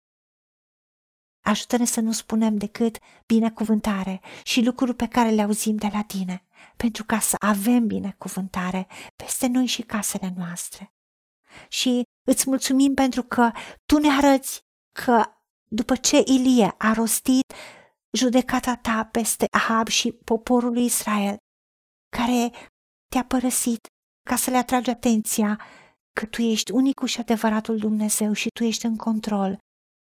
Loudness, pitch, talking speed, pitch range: -23 LUFS, 230 Hz, 135 wpm, 215-250 Hz